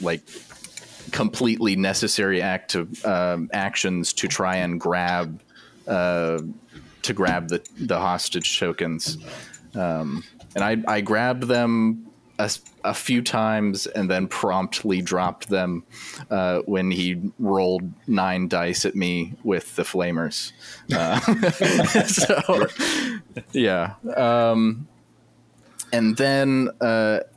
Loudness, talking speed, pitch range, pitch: -23 LUFS, 110 wpm, 90-120 Hz, 95 Hz